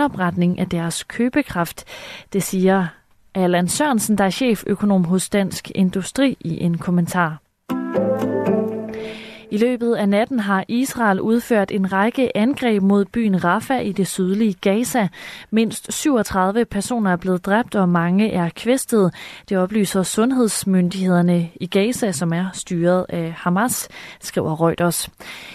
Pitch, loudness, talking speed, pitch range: 195 Hz, -19 LUFS, 130 wpm, 180-220 Hz